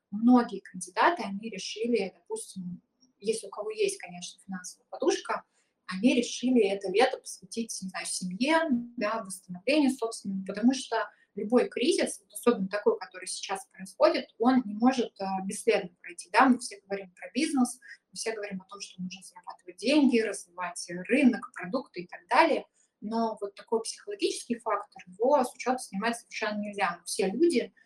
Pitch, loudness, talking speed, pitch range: 220 Hz, -29 LUFS, 155 wpm, 190-245 Hz